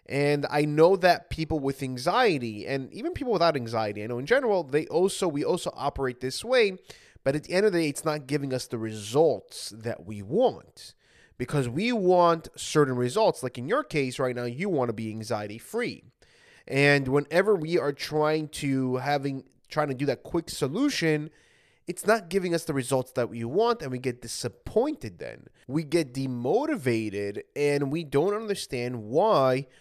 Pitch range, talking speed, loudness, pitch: 125-170 Hz, 185 wpm, -27 LUFS, 145 Hz